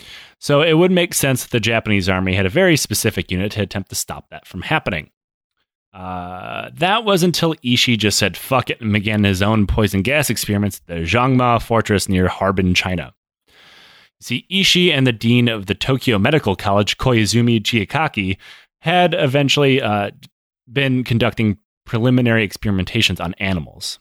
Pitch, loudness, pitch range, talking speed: 115 Hz, -17 LUFS, 100-130 Hz, 165 wpm